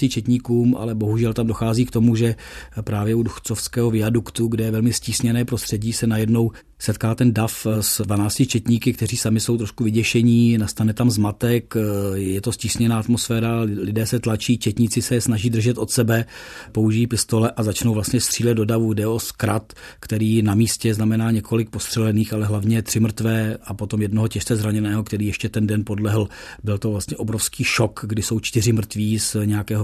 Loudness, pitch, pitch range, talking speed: -20 LUFS, 110 Hz, 110-115 Hz, 180 wpm